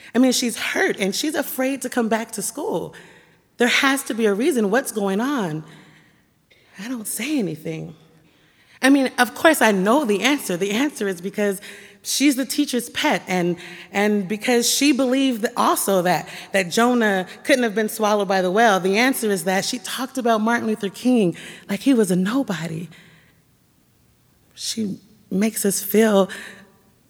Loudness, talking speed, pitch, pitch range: -20 LUFS, 170 wpm, 215 Hz, 190-255 Hz